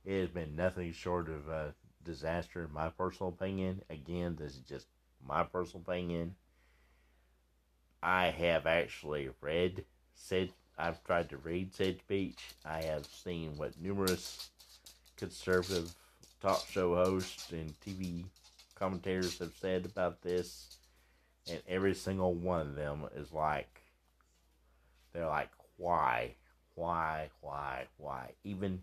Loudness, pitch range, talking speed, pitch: -37 LUFS, 65-90 Hz, 130 wpm, 85 Hz